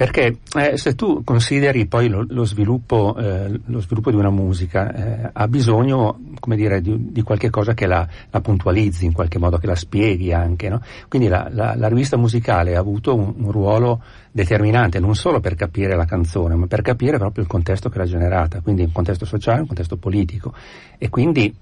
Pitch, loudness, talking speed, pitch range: 105 Hz, -19 LUFS, 195 wpm, 95-115 Hz